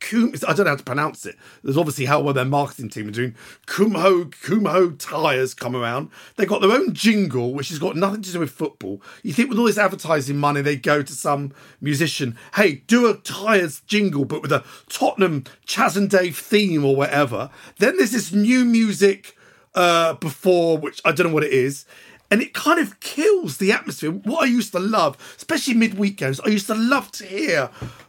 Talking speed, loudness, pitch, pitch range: 205 wpm, -20 LUFS, 175 Hz, 140-205 Hz